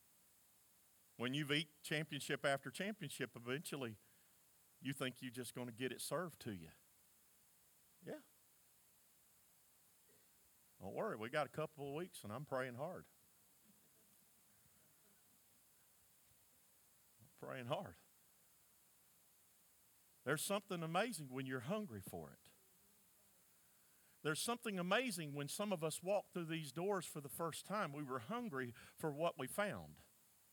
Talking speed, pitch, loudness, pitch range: 125 wpm, 150 Hz, -45 LUFS, 130-180 Hz